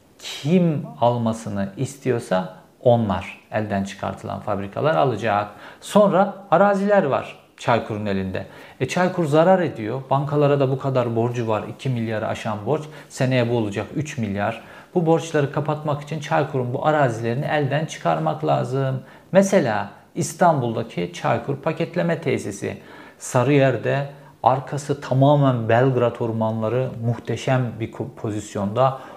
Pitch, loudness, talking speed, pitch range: 130 Hz, -22 LUFS, 115 wpm, 115-150 Hz